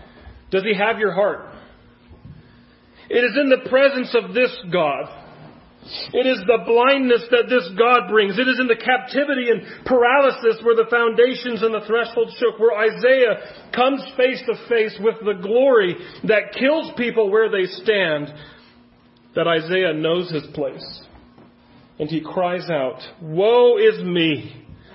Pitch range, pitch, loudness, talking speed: 190-250 Hz, 230 Hz, -18 LUFS, 150 wpm